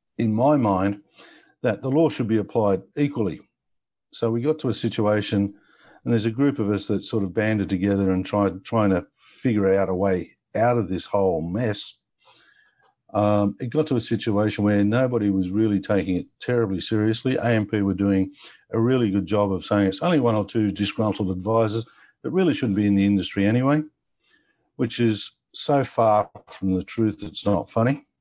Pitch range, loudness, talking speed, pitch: 100-115 Hz, -23 LUFS, 185 wpm, 105 Hz